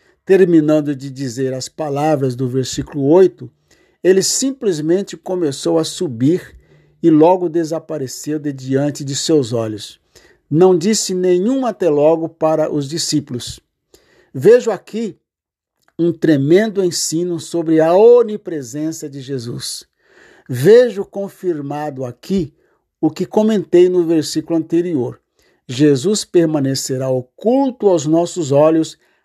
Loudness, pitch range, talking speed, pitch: -16 LUFS, 140-180 Hz, 110 wpm, 160 Hz